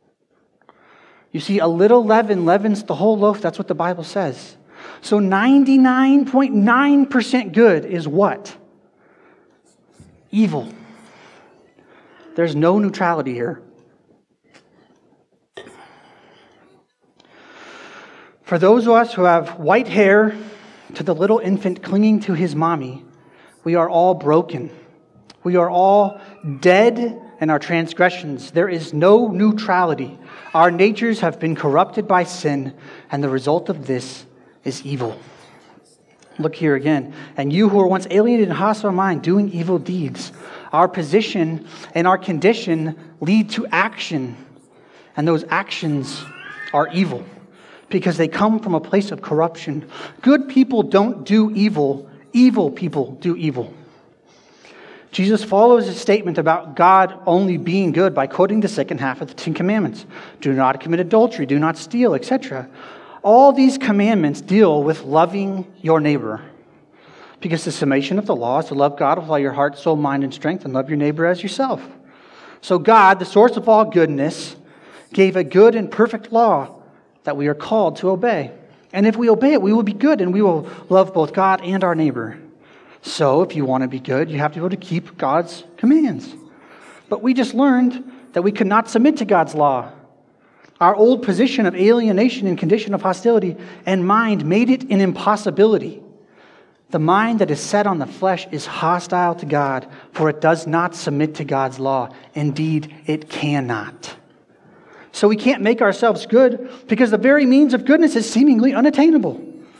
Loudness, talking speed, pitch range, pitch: -17 LUFS, 160 wpm, 160-215 Hz, 185 Hz